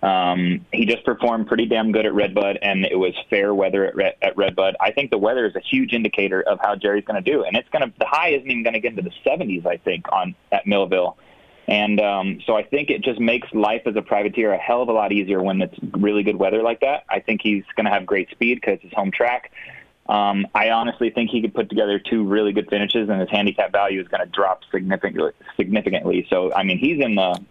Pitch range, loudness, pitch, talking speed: 100-115 Hz, -20 LUFS, 105 Hz, 255 wpm